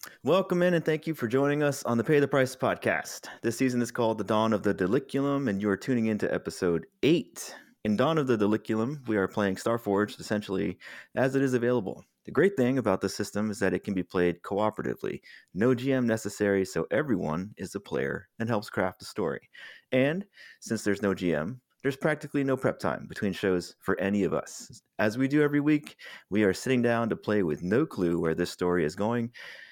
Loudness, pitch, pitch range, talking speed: -28 LUFS, 115 Hz, 100-135 Hz, 215 wpm